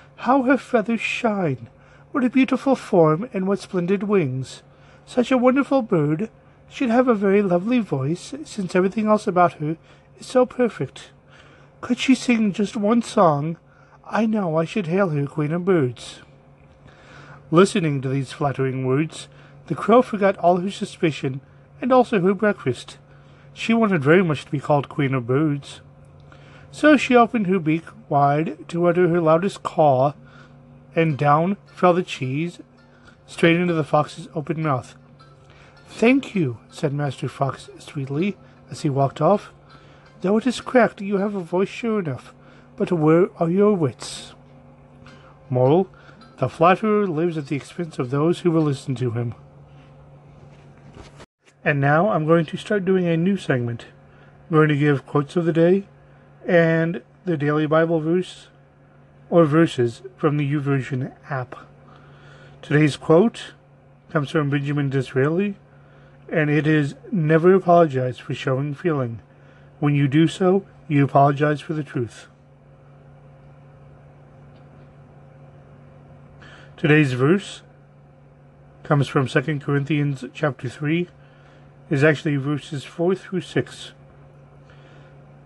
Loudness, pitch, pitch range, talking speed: -21 LUFS, 150 Hz, 135-180 Hz, 140 wpm